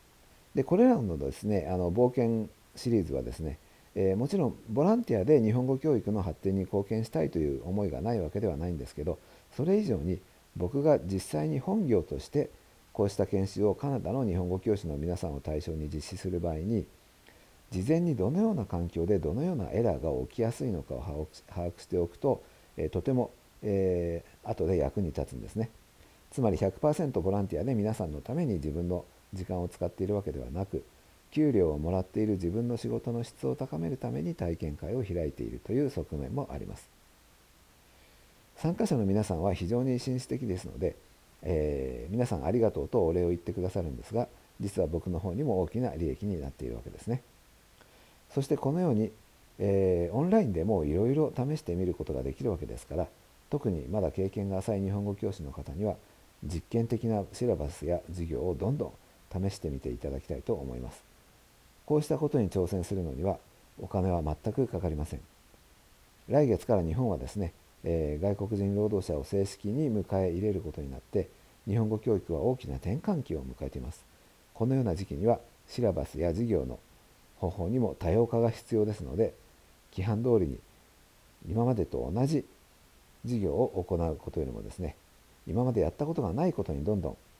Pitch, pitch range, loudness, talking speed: 95 Hz, 85-115 Hz, -31 LUFS, 380 characters per minute